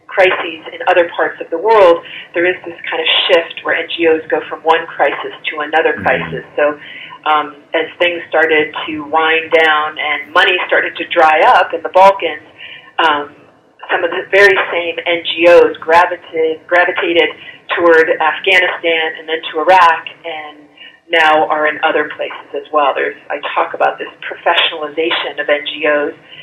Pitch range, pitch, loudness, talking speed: 155-180 Hz, 165 Hz, -13 LUFS, 160 wpm